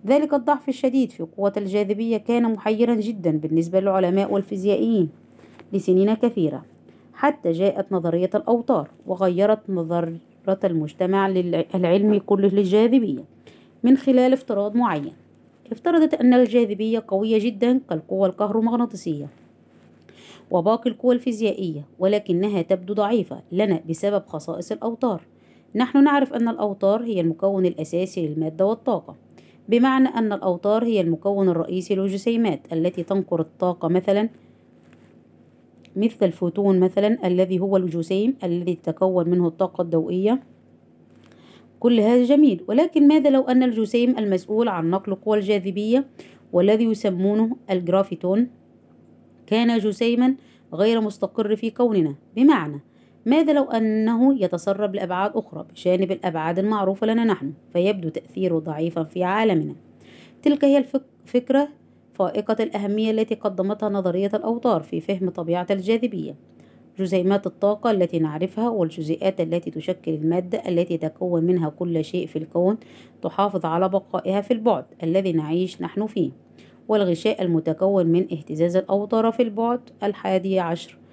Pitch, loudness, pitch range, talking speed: 195 Hz, -22 LUFS, 175-225 Hz, 120 wpm